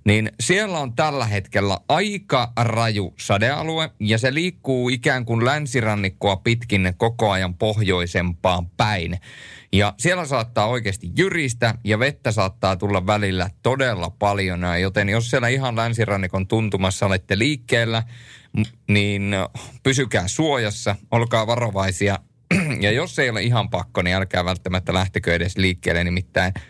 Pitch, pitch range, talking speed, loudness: 110 Hz, 95-125 Hz, 130 wpm, -21 LUFS